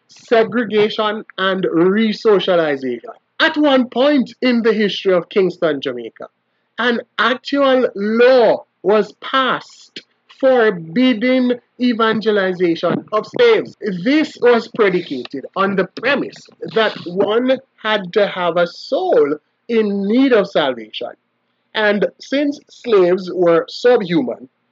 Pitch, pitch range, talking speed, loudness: 215 Hz, 185-250 Hz, 105 wpm, -16 LUFS